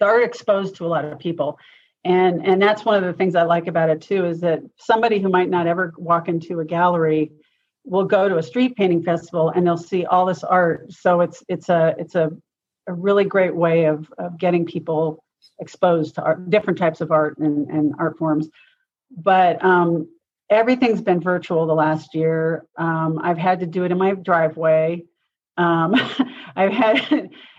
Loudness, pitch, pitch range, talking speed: -19 LUFS, 175 Hz, 165-190 Hz, 190 wpm